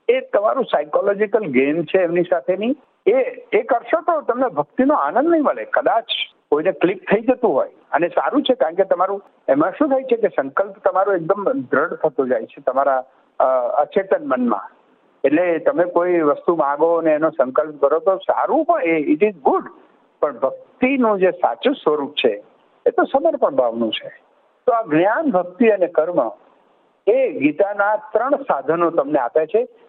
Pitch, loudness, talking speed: 210 Hz, -19 LUFS, 165 wpm